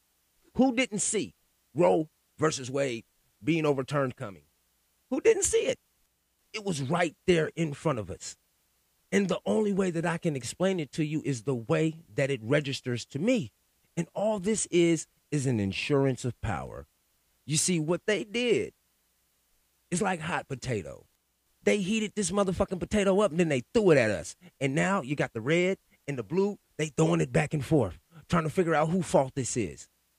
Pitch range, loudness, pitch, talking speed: 135-190 Hz, -28 LUFS, 160 Hz, 185 wpm